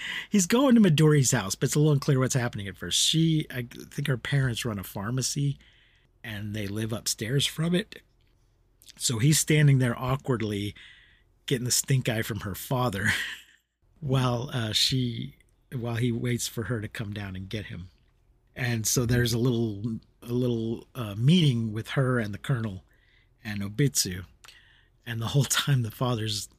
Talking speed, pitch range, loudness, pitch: 170 wpm, 110-135 Hz, -26 LUFS, 120 Hz